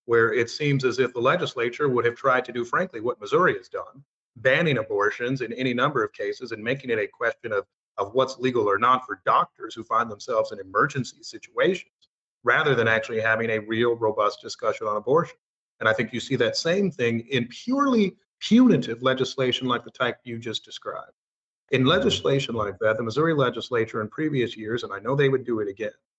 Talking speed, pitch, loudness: 205 wpm, 130 Hz, -24 LUFS